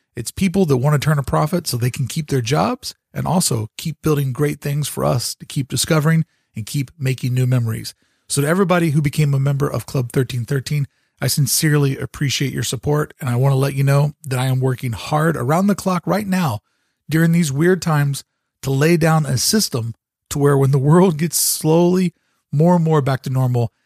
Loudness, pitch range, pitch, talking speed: -18 LUFS, 130-160 Hz, 145 Hz, 210 wpm